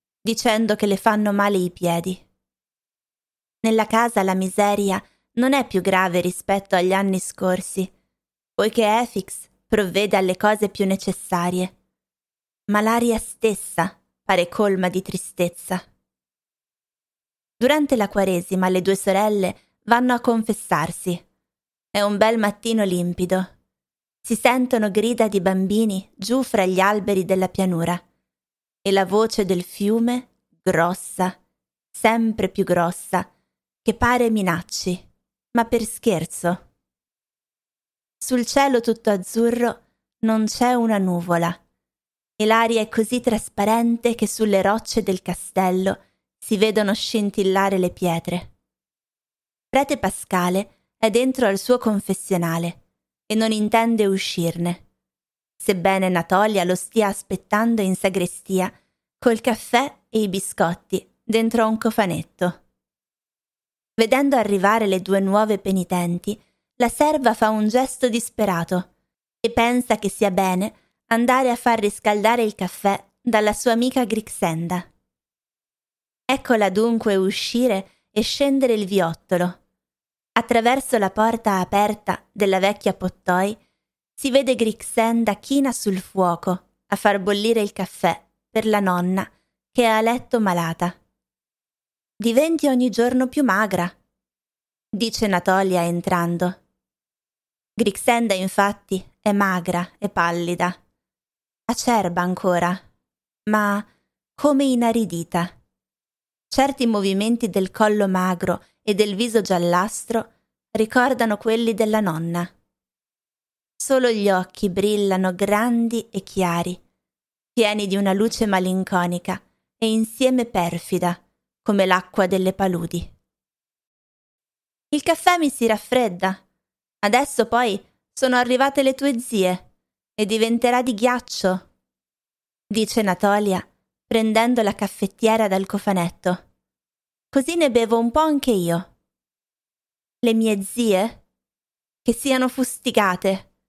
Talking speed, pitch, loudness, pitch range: 110 wpm, 205 Hz, -21 LUFS, 185-230 Hz